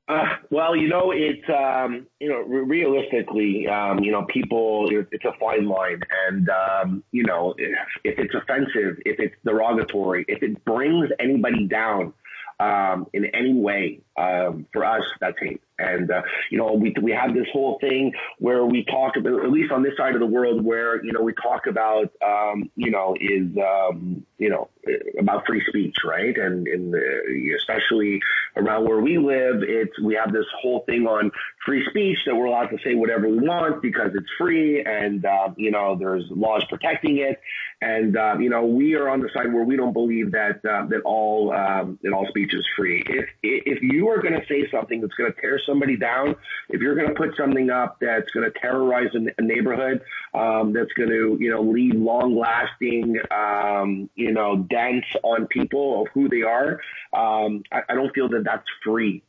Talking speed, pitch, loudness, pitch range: 195 wpm, 115 Hz, -22 LUFS, 105-130 Hz